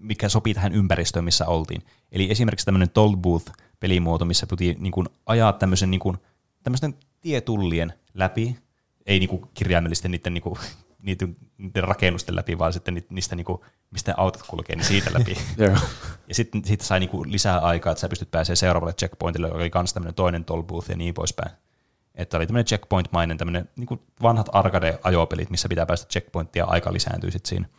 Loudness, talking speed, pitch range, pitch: -24 LUFS, 165 wpm, 85-105 Hz, 95 Hz